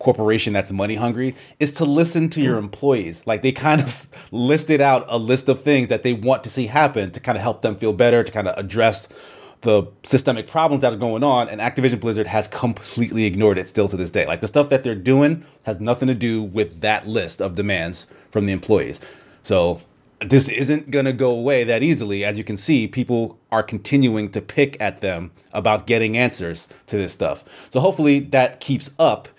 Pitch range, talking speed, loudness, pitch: 105-135 Hz, 210 wpm, -19 LUFS, 120 Hz